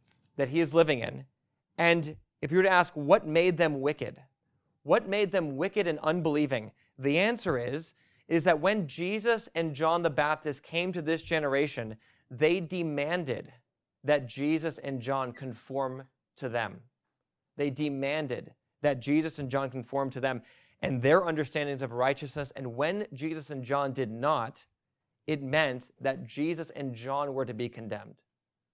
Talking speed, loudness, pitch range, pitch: 160 wpm, -30 LUFS, 135-165 Hz, 145 Hz